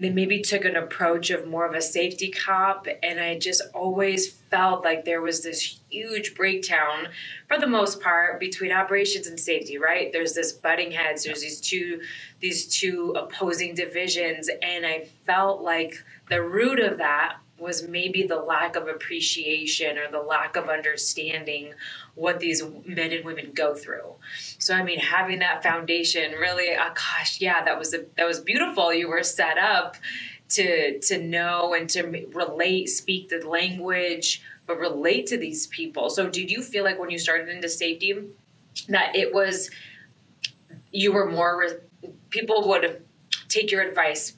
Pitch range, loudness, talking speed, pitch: 165-190 Hz, -24 LUFS, 165 wpm, 175 Hz